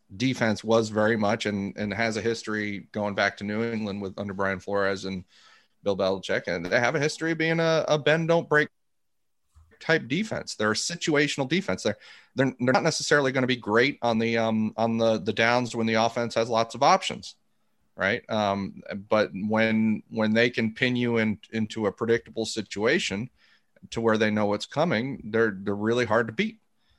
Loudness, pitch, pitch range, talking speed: -26 LUFS, 110 Hz, 105-120 Hz, 195 wpm